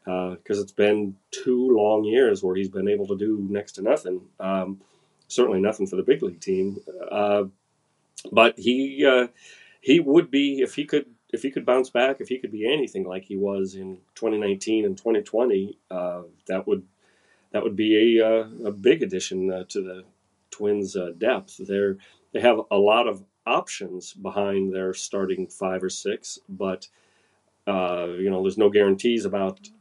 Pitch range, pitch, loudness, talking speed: 95-110 Hz, 100 Hz, -24 LUFS, 175 wpm